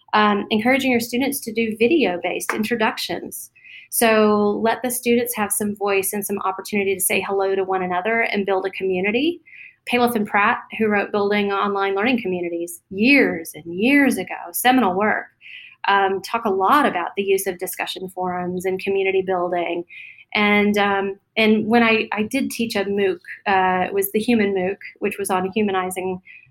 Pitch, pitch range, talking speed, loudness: 205 Hz, 190-230 Hz, 175 wpm, -20 LUFS